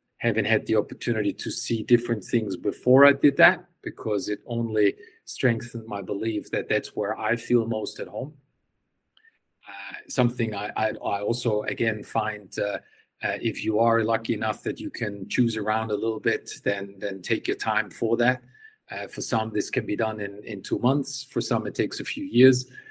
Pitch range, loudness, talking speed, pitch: 105-125 Hz, -25 LUFS, 195 wpm, 115 Hz